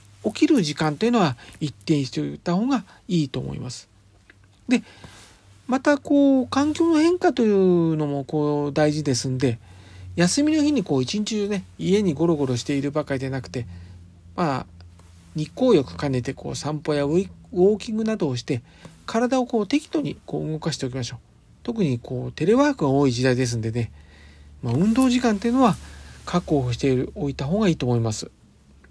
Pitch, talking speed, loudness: 145 Hz, 350 characters per minute, -23 LUFS